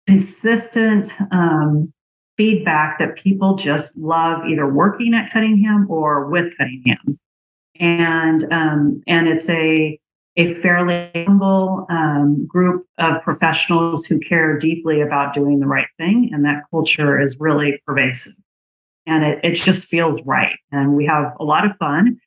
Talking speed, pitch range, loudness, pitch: 145 wpm, 150-180 Hz, -16 LUFS, 165 Hz